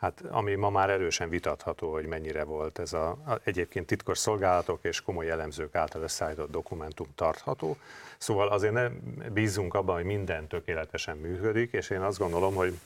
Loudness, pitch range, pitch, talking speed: -31 LUFS, 80-105 Hz, 95 Hz, 170 wpm